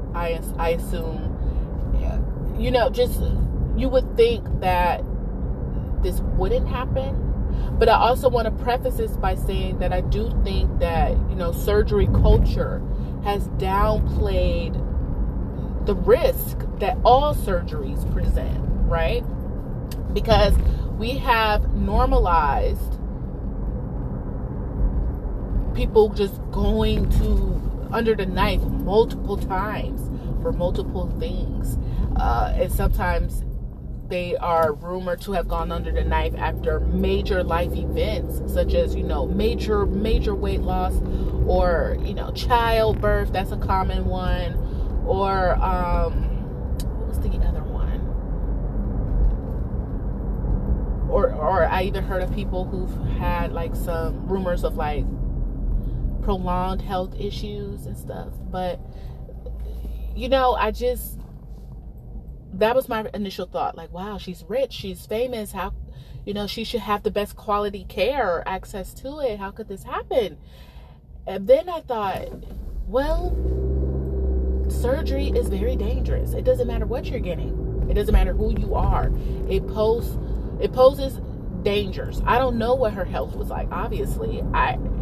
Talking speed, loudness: 130 wpm, -24 LUFS